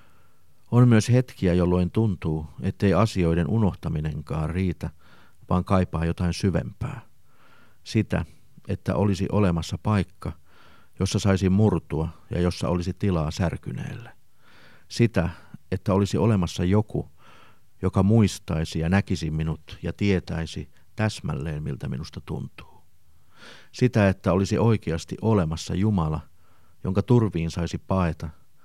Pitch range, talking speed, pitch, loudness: 85-100 Hz, 110 wpm, 95 Hz, -25 LUFS